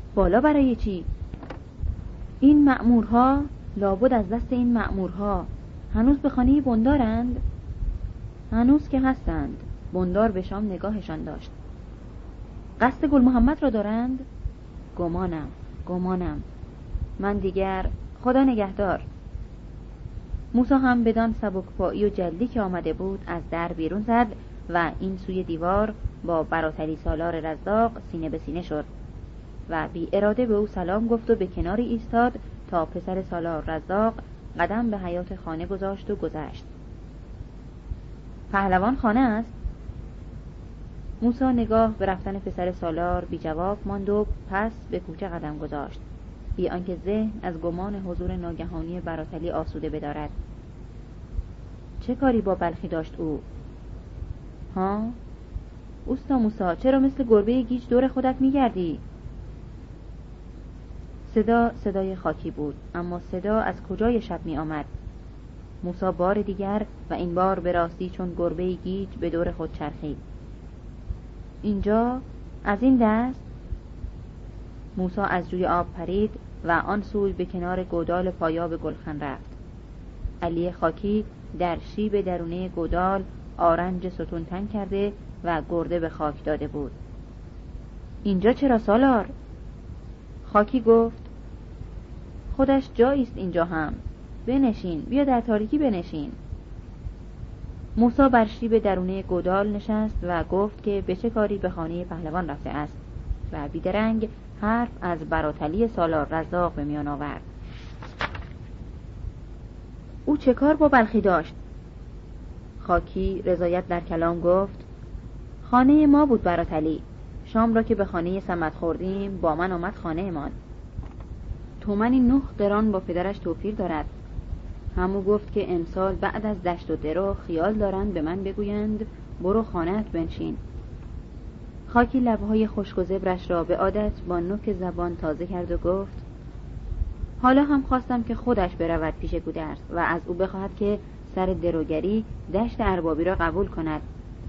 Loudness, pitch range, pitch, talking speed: -25 LUFS, 170-220 Hz, 185 Hz, 130 wpm